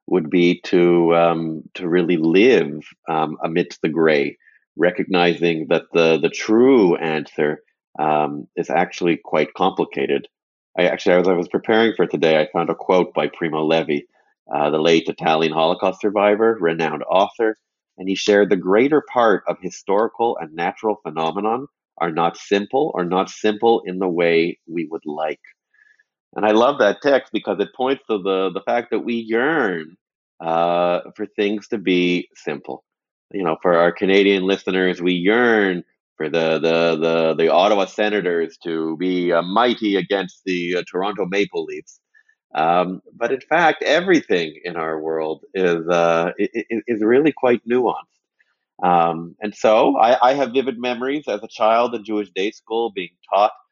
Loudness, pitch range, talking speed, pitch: -19 LUFS, 85-110 Hz, 160 wpm, 95 Hz